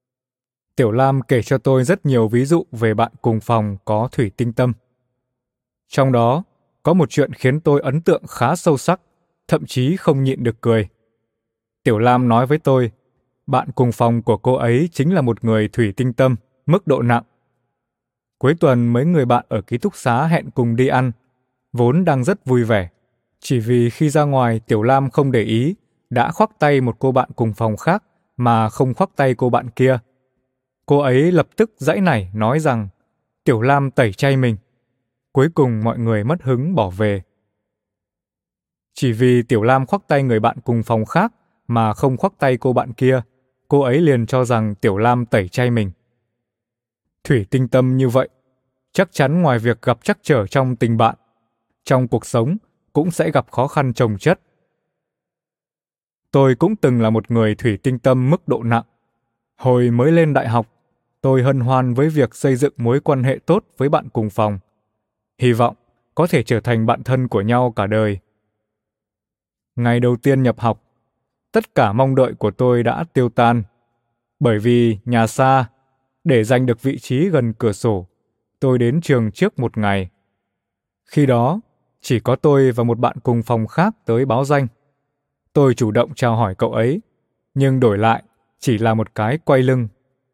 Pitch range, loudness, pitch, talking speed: 115-135 Hz, -17 LUFS, 125 Hz, 185 wpm